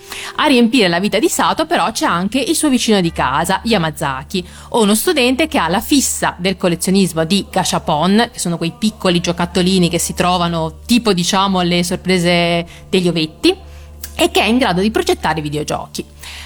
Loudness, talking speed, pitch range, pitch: -15 LUFS, 170 wpm, 170-235 Hz, 185 Hz